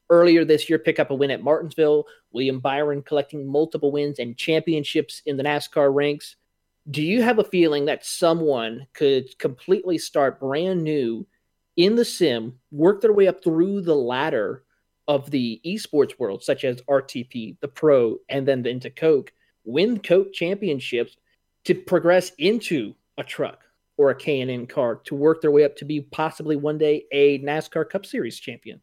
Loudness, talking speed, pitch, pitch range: -22 LUFS, 175 wpm, 150 Hz, 140-175 Hz